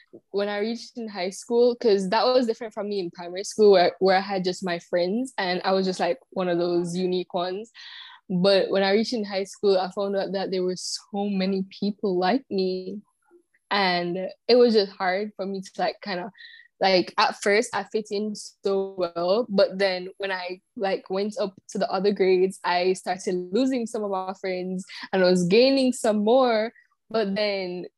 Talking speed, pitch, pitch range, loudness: 205 wpm, 195 Hz, 185-220 Hz, -24 LUFS